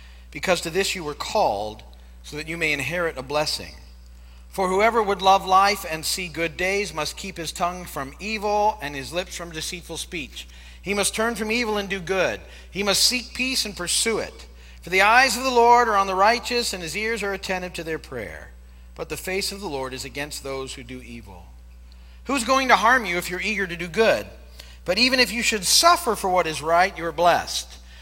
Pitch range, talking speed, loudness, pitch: 130-200 Hz, 220 wpm, -22 LUFS, 175 Hz